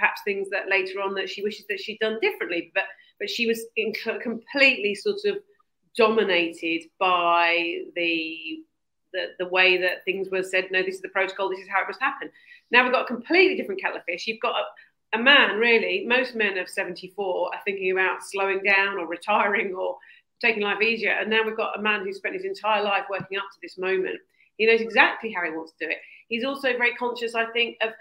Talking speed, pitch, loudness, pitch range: 220 wpm, 215 Hz, -23 LUFS, 190-245 Hz